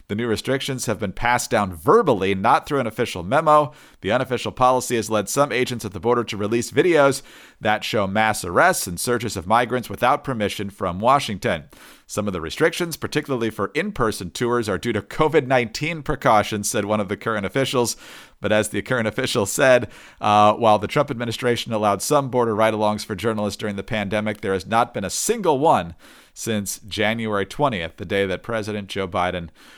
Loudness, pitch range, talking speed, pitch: -21 LUFS, 105-125 Hz, 185 wpm, 110 Hz